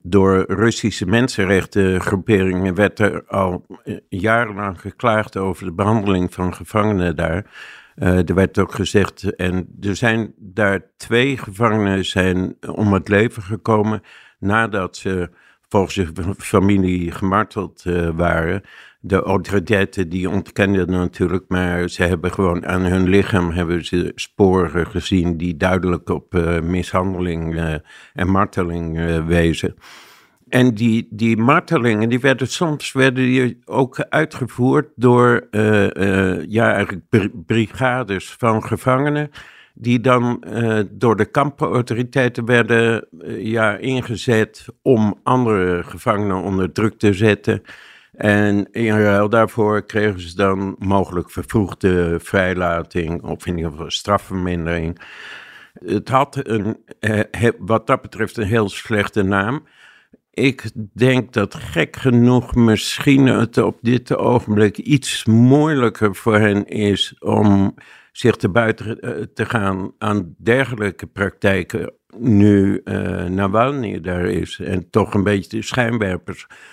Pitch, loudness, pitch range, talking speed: 100 Hz, -18 LUFS, 95-115 Hz, 125 wpm